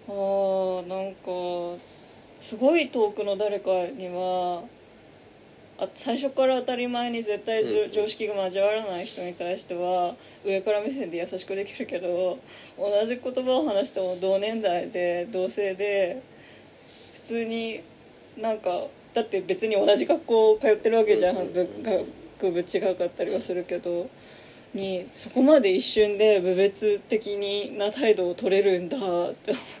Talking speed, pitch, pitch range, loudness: 265 characters per minute, 200 Hz, 185-225 Hz, -26 LUFS